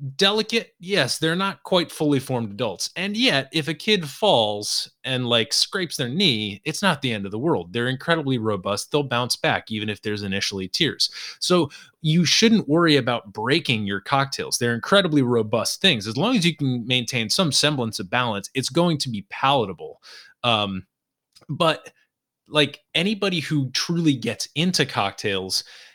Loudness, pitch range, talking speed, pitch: -22 LUFS, 115-170 Hz, 170 wpm, 135 Hz